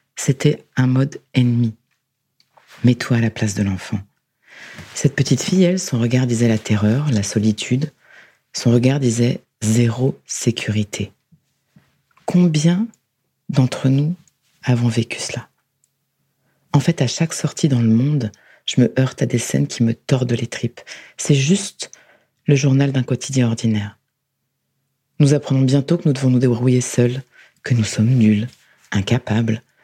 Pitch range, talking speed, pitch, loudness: 115-140 Hz, 145 wpm, 130 Hz, -18 LUFS